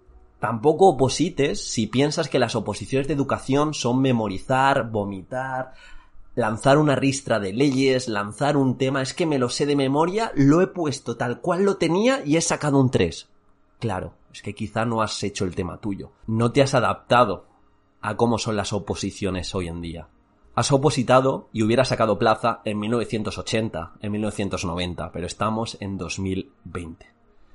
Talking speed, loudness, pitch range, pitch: 165 wpm, -23 LUFS, 105-135 Hz, 120 Hz